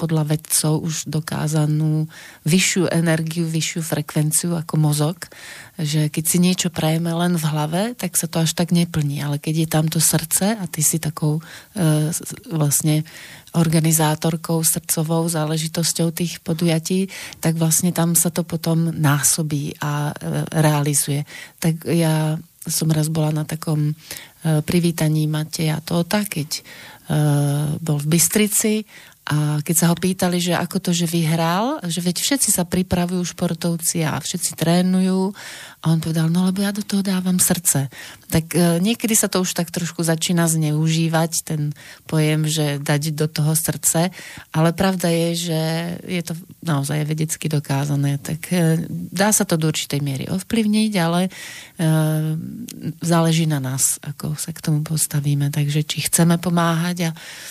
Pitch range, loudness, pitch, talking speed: 155-175 Hz, -20 LUFS, 165 Hz, 150 wpm